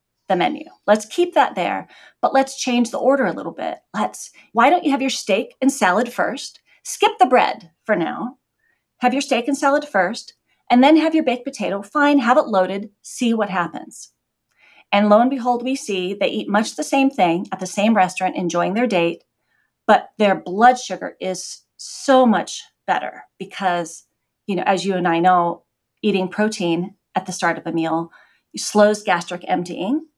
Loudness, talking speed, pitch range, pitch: -19 LUFS, 185 wpm, 185-270 Hz, 210 Hz